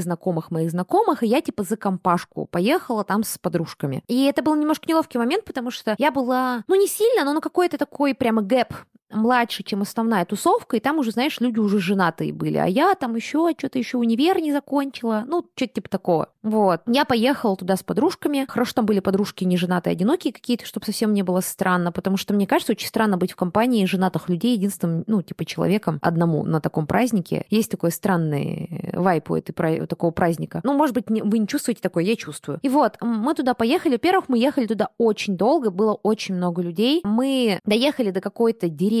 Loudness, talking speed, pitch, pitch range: -22 LUFS, 200 wpm, 220 Hz, 185-260 Hz